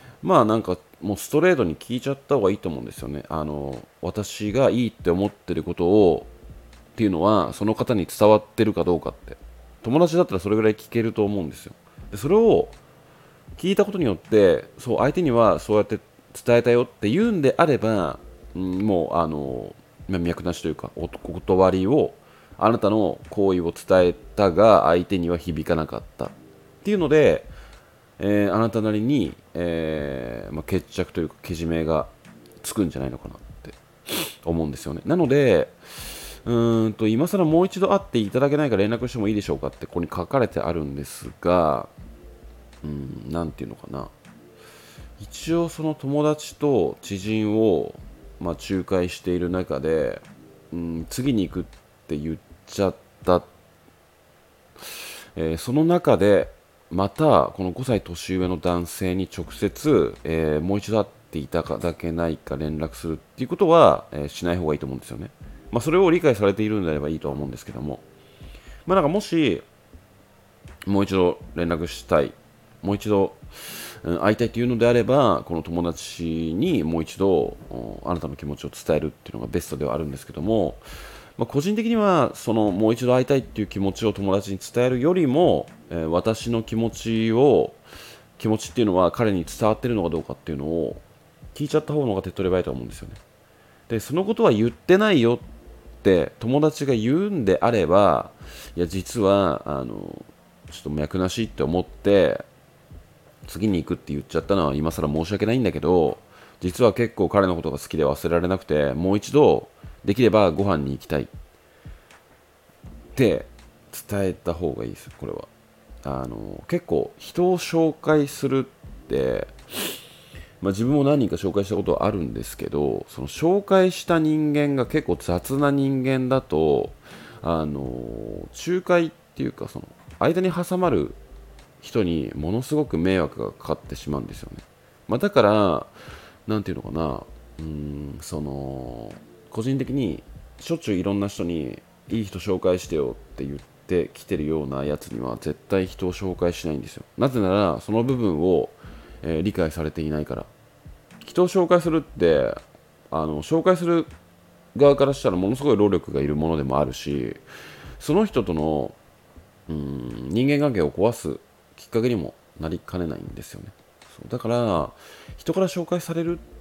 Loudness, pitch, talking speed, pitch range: -23 LUFS, 95 Hz, 335 characters per minute, 80-120 Hz